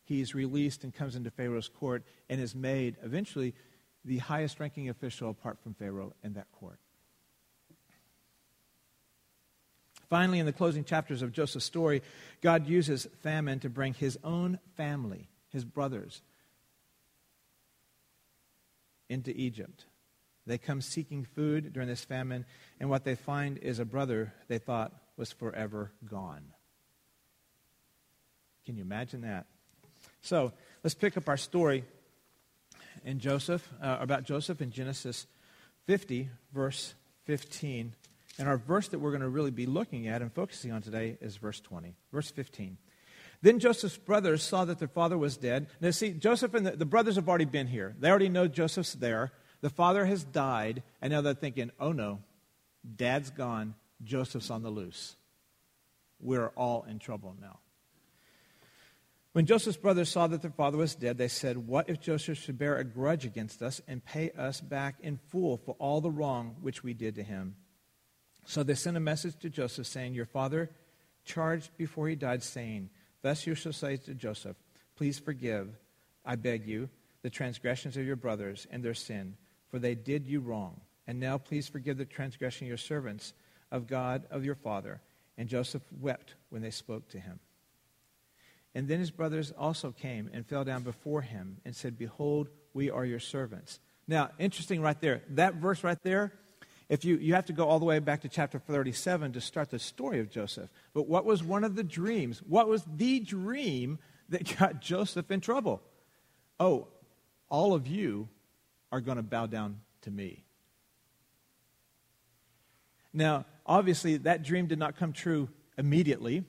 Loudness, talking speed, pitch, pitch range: -33 LUFS, 165 wpm, 140 Hz, 120-160 Hz